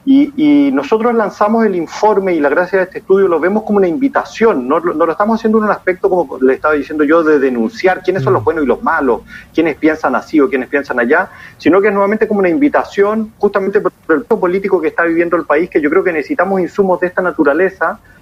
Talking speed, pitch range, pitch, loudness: 235 wpm, 165-215 Hz, 190 Hz, -13 LUFS